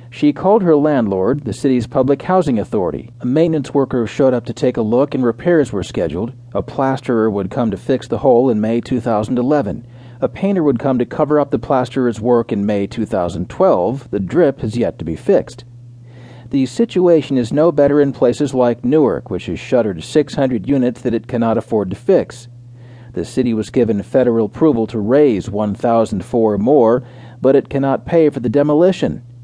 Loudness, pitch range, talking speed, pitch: -16 LUFS, 115-140 Hz, 185 wpm, 125 Hz